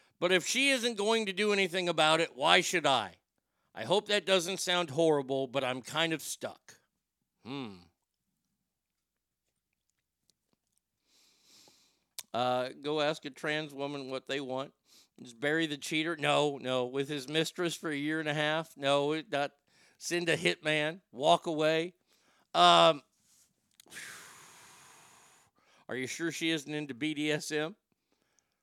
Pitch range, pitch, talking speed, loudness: 140-170 Hz, 155 Hz, 135 wpm, -30 LUFS